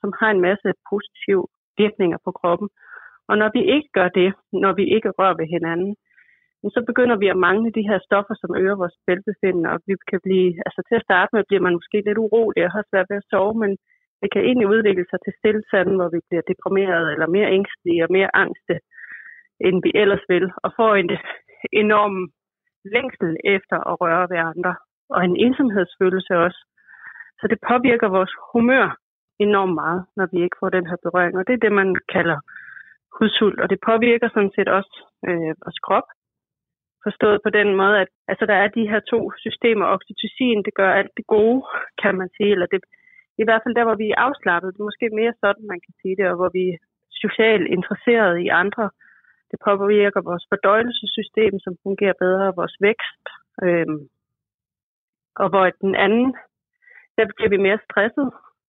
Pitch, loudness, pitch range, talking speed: 200 Hz, -19 LUFS, 185-220 Hz, 190 wpm